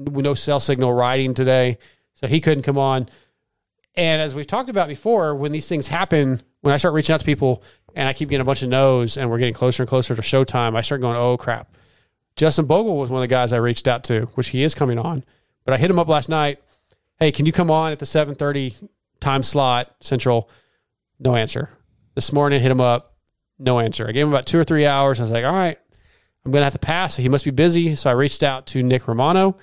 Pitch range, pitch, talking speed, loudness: 125-155 Hz, 135 Hz, 245 wpm, -19 LUFS